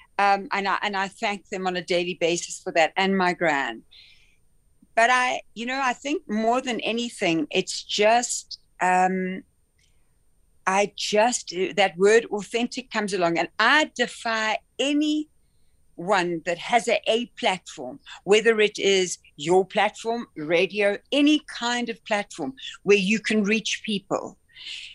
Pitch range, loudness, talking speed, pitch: 185-235 Hz, -23 LUFS, 140 wpm, 205 Hz